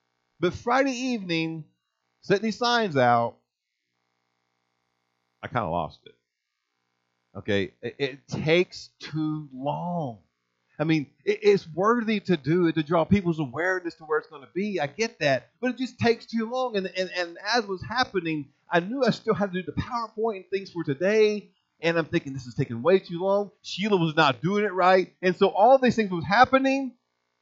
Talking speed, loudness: 185 wpm, -25 LUFS